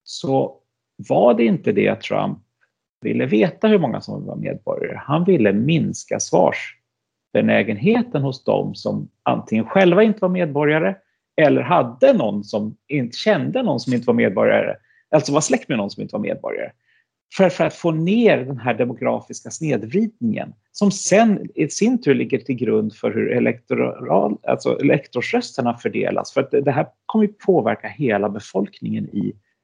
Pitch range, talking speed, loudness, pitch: 130-215 Hz, 160 wpm, -19 LUFS, 175 Hz